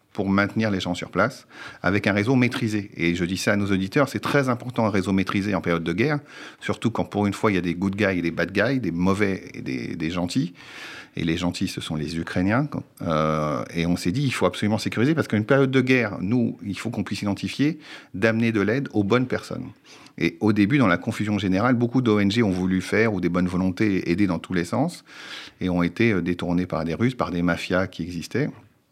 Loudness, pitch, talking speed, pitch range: -23 LUFS, 100 Hz, 240 wpm, 90-115 Hz